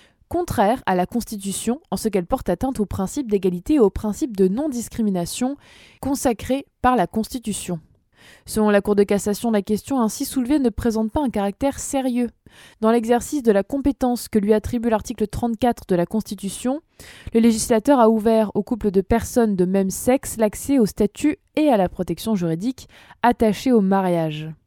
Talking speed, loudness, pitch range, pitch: 175 wpm, -21 LUFS, 200-255 Hz, 220 Hz